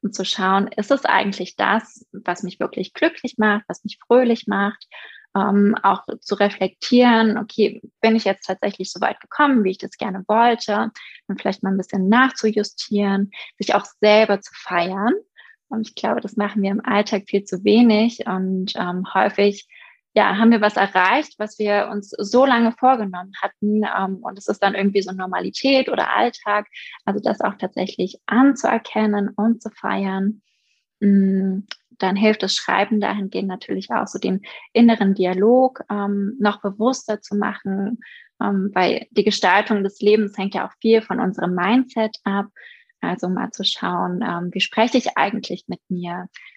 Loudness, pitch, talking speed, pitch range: -20 LUFS, 205 Hz, 160 wpm, 195-225 Hz